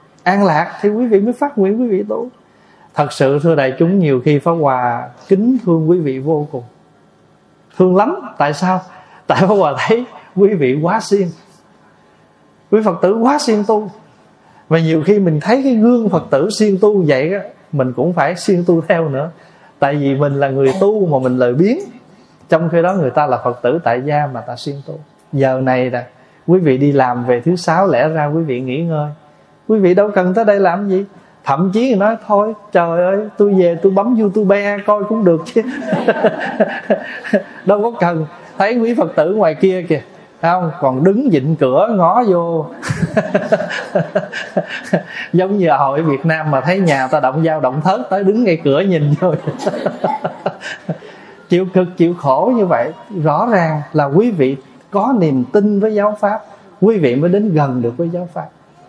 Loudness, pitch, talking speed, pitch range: -14 LUFS, 175 Hz, 195 wpm, 150-205 Hz